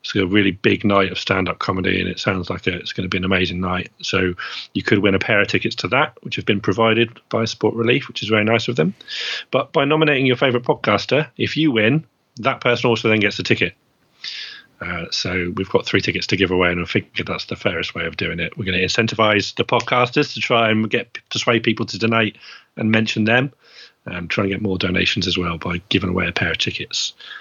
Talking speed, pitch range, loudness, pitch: 240 wpm, 95-120 Hz, -19 LUFS, 110 Hz